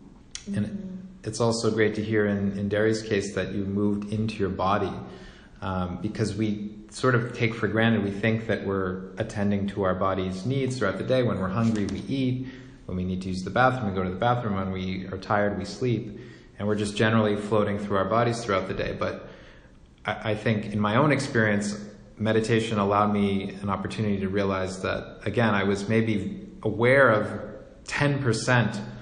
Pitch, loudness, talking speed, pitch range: 105 Hz, -26 LUFS, 190 wpm, 100-115 Hz